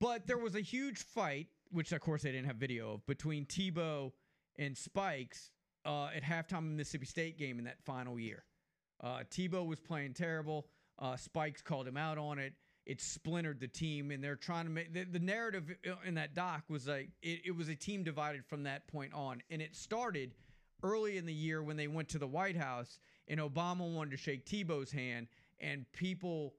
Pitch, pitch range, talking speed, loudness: 155 Hz, 140-175 Hz, 210 wpm, -42 LUFS